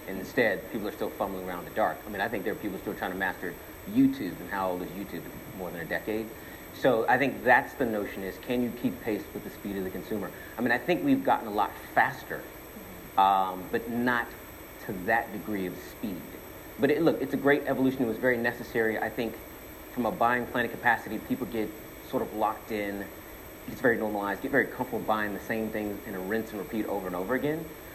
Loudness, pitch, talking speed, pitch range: -29 LUFS, 110 Hz, 230 wpm, 100-125 Hz